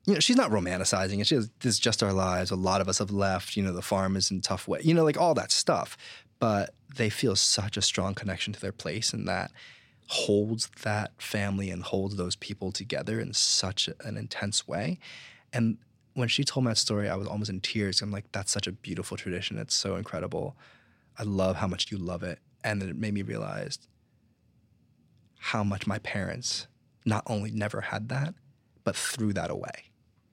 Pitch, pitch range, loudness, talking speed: 105 Hz, 95-115 Hz, -29 LUFS, 210 wpm